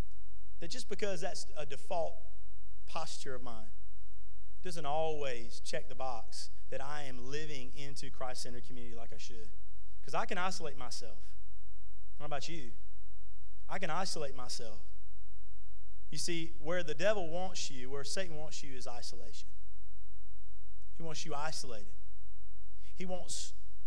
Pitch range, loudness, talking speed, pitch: 95-150 Hz, -41 LUFS, 140 wpm, 115 Hz